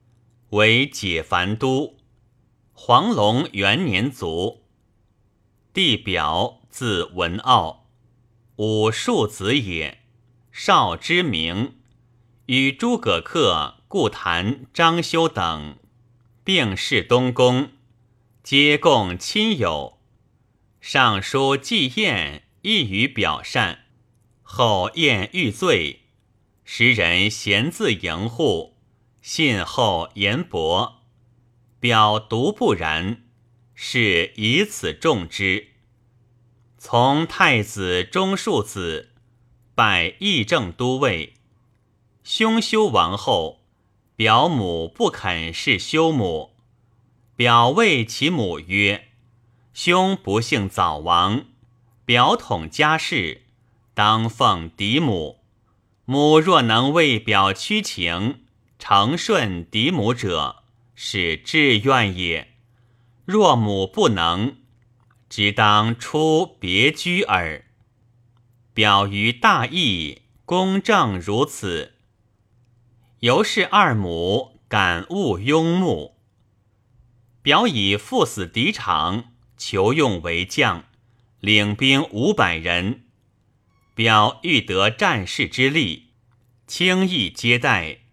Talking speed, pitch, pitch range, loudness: 120 characters per minute, 120 Hz, 105-125 Hz, -19 LUFS